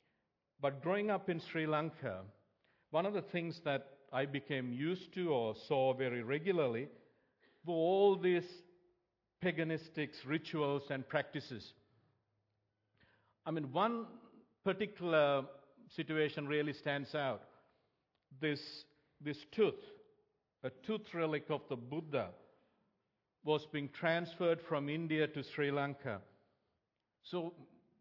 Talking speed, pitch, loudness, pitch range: 110 wpm, 150 Hz, -38 LUFS, 135-175 Hz